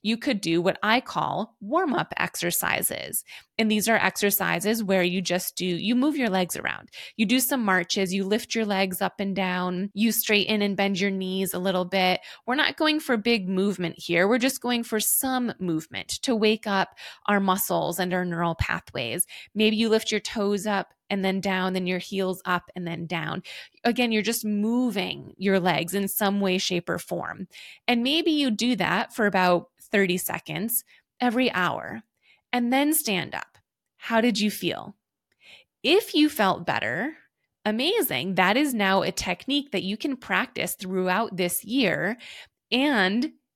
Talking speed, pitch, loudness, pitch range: 180 wpm, 200 Hz, -25 LUFS, 185-235 Hz